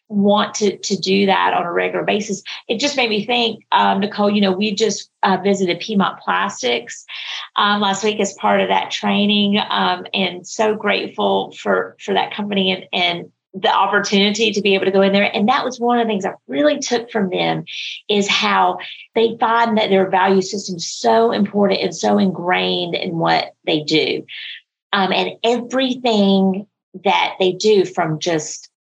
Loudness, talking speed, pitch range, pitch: -17 LUFS, 185 wpm, 190-220 Hz, 200 Hz